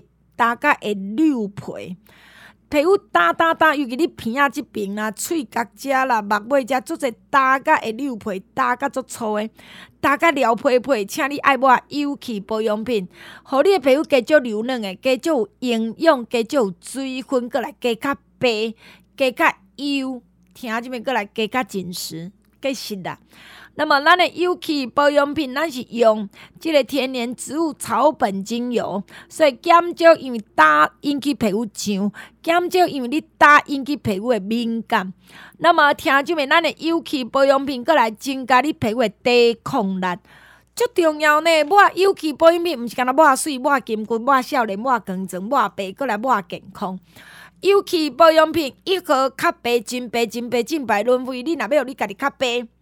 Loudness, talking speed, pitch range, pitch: -19 LUFS, 245 characters per minute, 220-300 Hz, 260 Hz